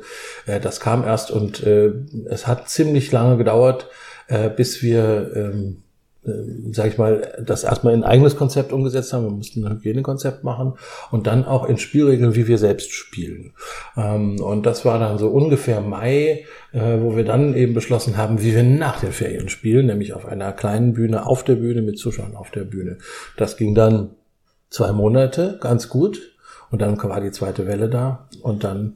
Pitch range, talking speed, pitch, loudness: 105-130 Hz, 185 wpm, 115 Hz, -19 LUFS